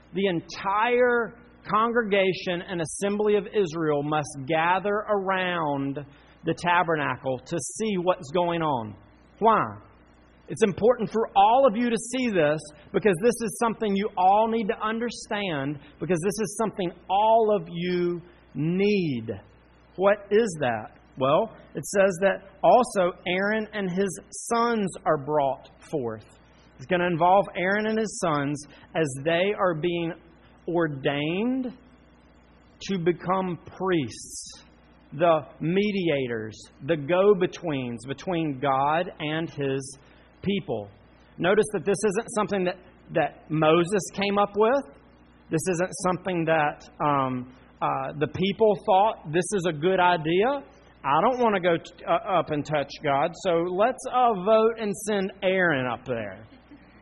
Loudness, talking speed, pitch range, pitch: -25 LUFS, 135 wpm, 150-205 Hz, 180 Hz